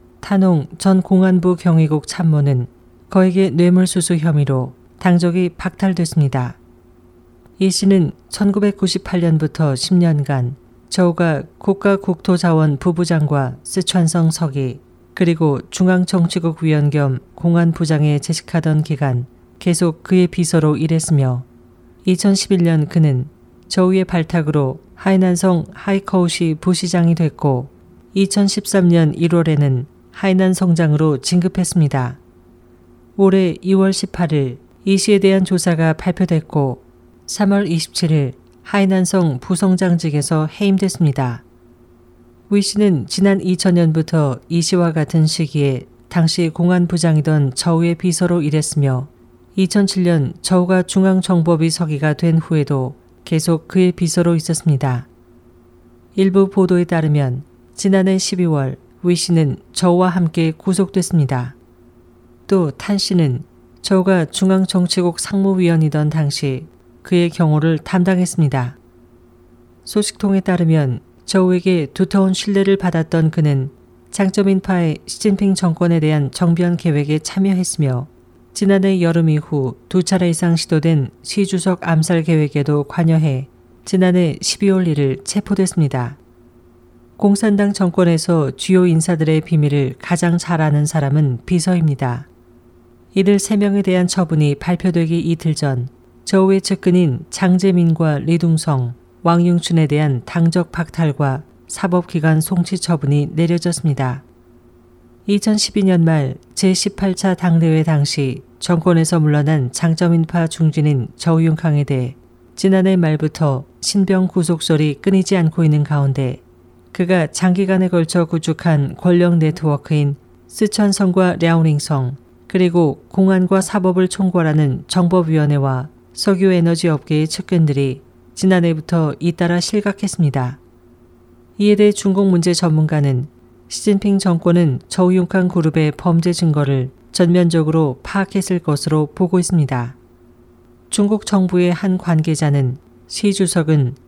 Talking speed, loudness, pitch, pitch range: 265 characters per minute, -16 LUFS, 165 Hz, 140-185 Hz